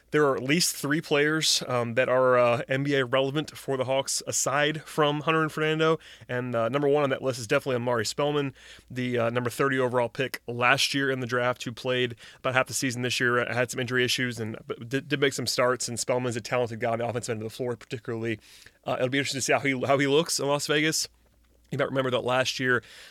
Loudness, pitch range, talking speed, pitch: -26 LUFS, 120-140 Hz, 240 wpm, 130 Hz